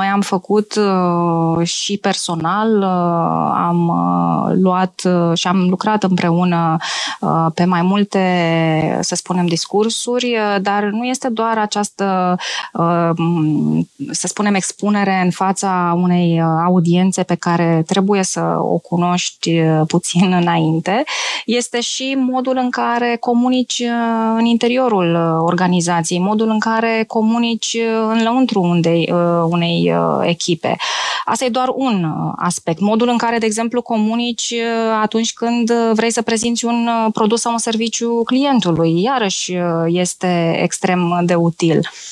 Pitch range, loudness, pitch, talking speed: 170-230 Hz, -16 LUFS, 190 Hz, 115 wpm